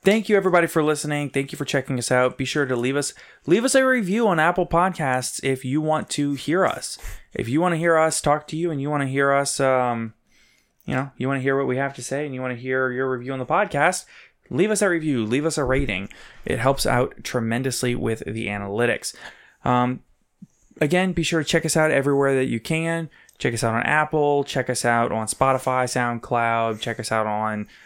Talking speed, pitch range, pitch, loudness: 235 wpm, 125-155 Hz, 135 Hz, -22 LUFS